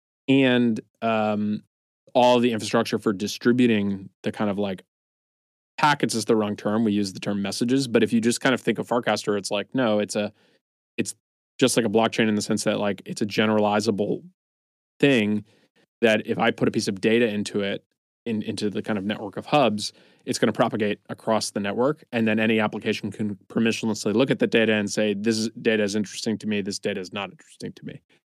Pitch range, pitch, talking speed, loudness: 105-115 Hz, 110 Hz, 210 wpm, -24 LUFS